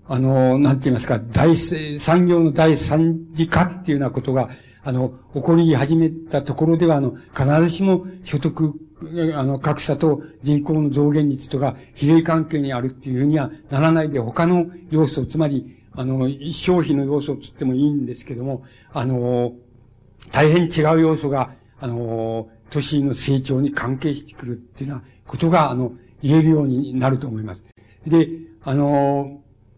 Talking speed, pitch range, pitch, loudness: 320 characters per minute, 130-155 Hz, 140 Hz, -19 LUFS